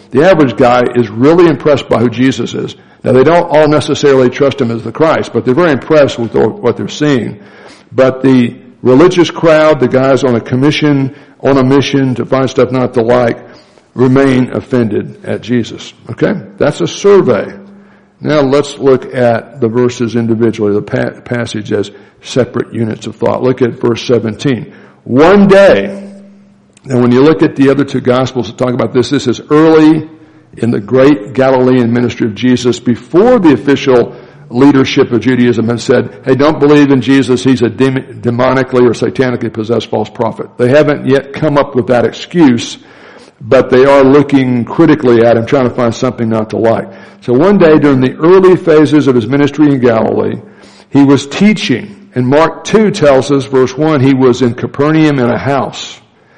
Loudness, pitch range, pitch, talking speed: -9 LUFS, 120-145 Hz, 130 Hz, 180 wpm